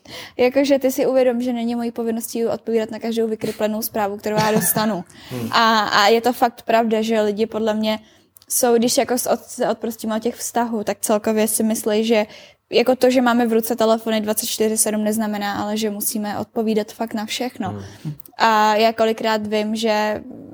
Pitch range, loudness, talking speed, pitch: 215-235 Hz, -19 LUFS, 175 wpm, 220 Hz